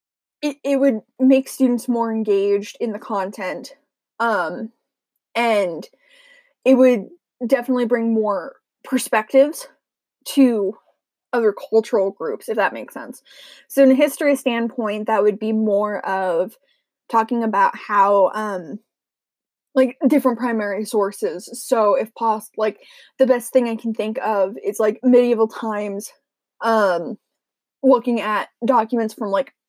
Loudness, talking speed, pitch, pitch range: -19 LUFS, 130 wpm, 235 Hz, 215-265 Hz